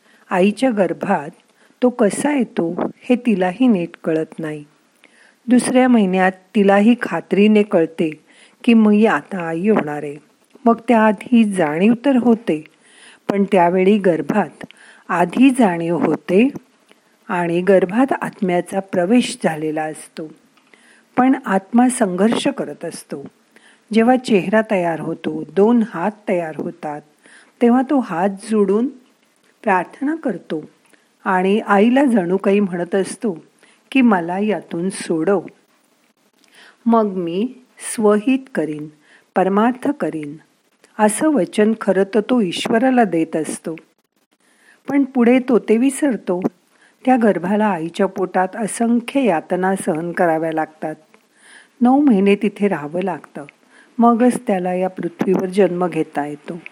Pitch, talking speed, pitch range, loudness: 205 Hz, 115 wpm, 175-235 Hz, -17 LUFS